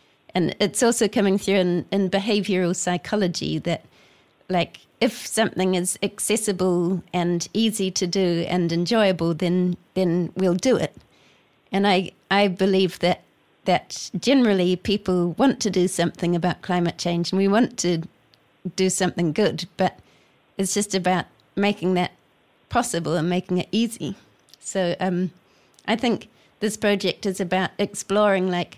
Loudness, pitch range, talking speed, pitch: -23 LUFS, 175-200 Hz, 145 wpm, 185 Hz